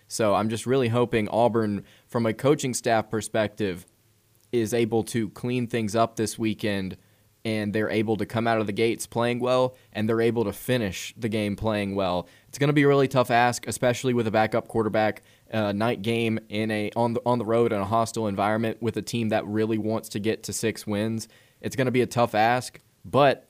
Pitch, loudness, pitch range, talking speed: 110 Hz, -25 LUFS, 105-120 Hz, 215 wpm